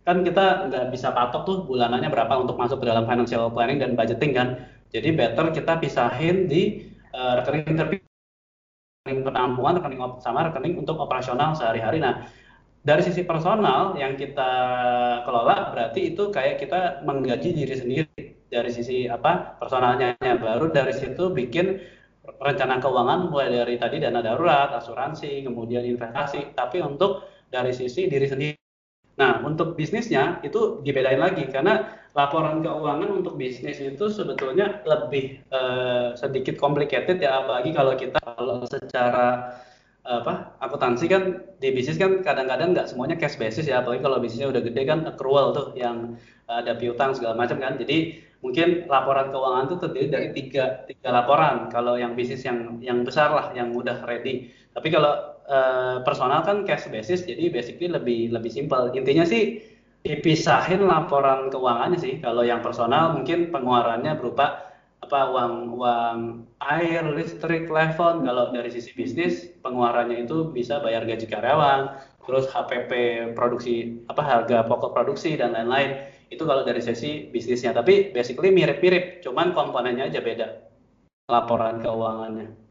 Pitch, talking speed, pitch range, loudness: 135 Hz, 145 wpm, 120-160 Hz, -23 LUFS